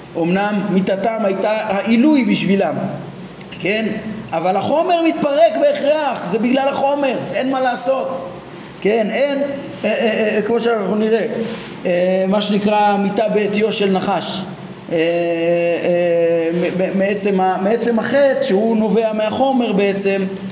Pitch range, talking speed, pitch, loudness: 185-235 Hz, 115 wpm, 210 Hz, -17 LUFS